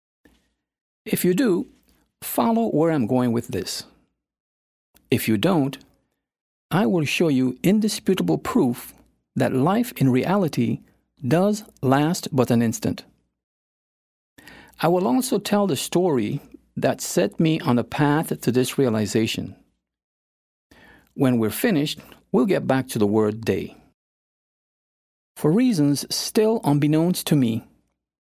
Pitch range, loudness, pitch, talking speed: 115-180 Hz, -22 LUFS, 130 Hz, 125 wpm